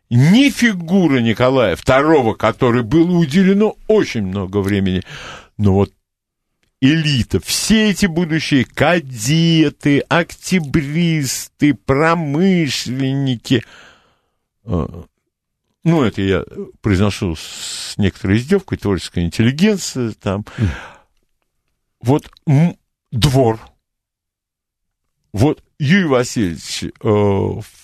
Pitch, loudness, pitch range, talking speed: 130 Hz, -16 LUFS, 100-165 Hz, 75 wpm